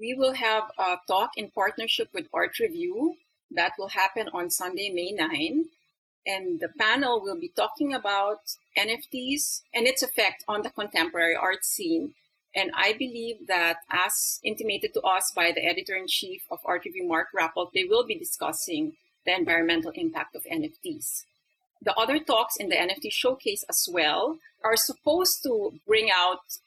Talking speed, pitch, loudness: 165 wpm, 245 Hz, -26 LUFS